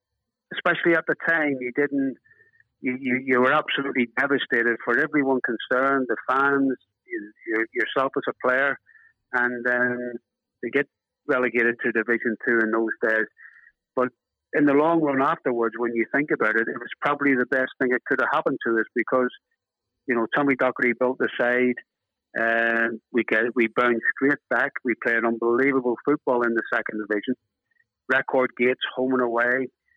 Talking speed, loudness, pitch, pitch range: 170 wpm, -23 LUFS, 125 Hz, 120-140 Hz